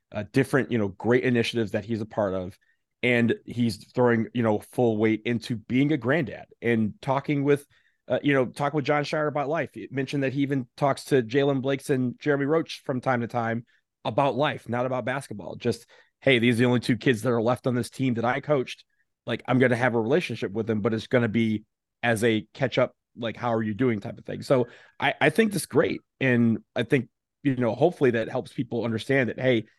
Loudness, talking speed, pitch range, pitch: -25 LUFS, 235 wpm, 115-135 Hz, 125 Hz